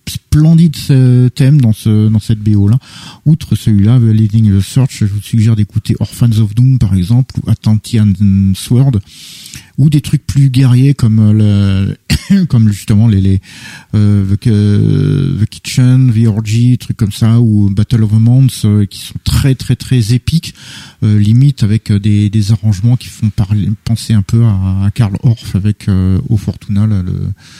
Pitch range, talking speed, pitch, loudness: 105-125 Hz, 175 wpm, 110 Hz, -11 LUFS